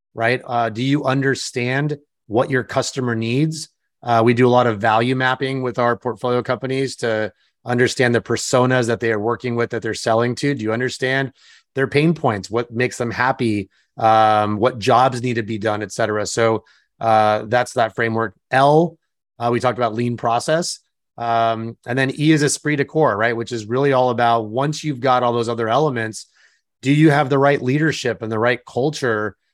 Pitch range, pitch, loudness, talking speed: 115-135 Hz, 125 Hz, -19 LUFS, 195 wpm